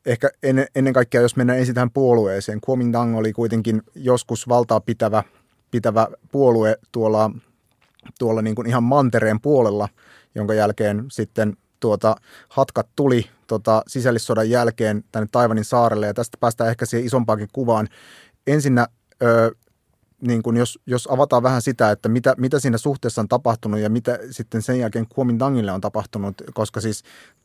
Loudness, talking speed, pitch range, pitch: -20 LUFS, 145 wpm, 110-125 Hz, 115 Hz